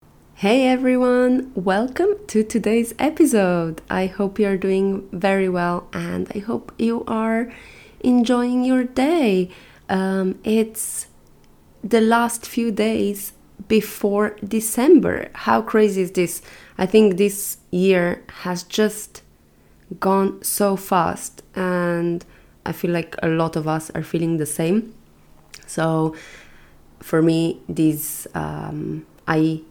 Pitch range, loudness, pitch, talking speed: 165-220 Hz, -20 LUFS, 195 Hz, 120 wpm